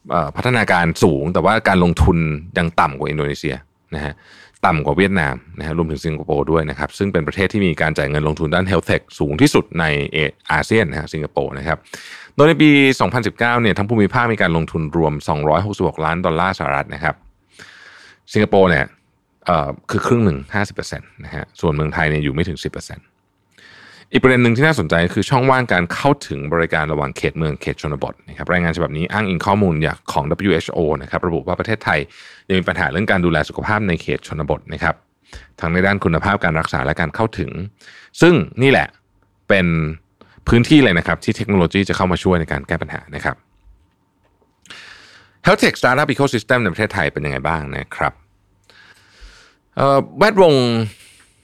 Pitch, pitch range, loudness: 90 Hz, 80-105 Hz, -17 LUFS